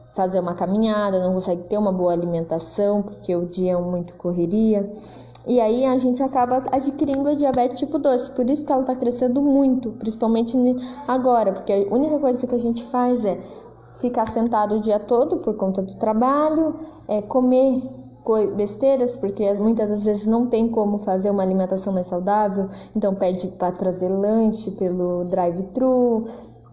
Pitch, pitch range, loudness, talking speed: 215 Hz, 190-250 Hz, -21 LUFS, 165 wpm